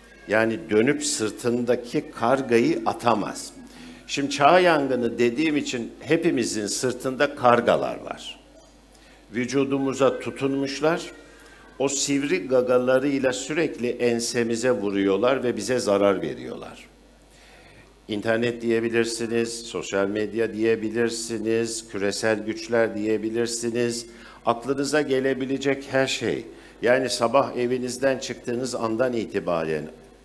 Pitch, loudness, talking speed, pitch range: 120 Hz, -24 LUFS, 85 wpm, 115-135 Hz